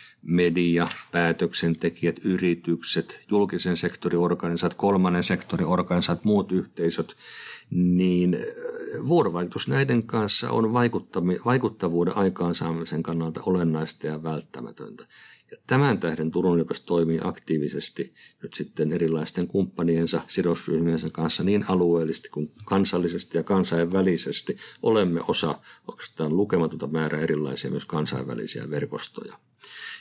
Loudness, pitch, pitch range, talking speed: -25 LUFS, 85 Hz, 80-95 Hz, 100 wpm